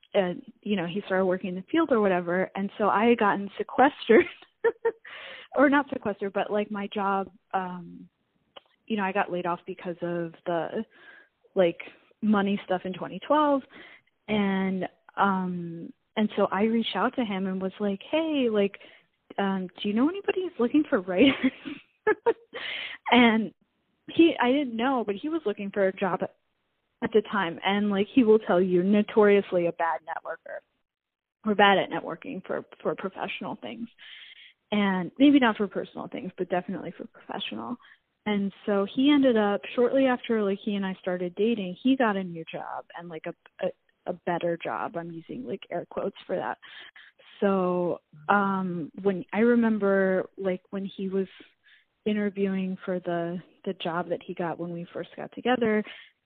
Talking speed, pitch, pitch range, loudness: 170 wpm, 200 Hz, 185-235 Hz, -27 LUFS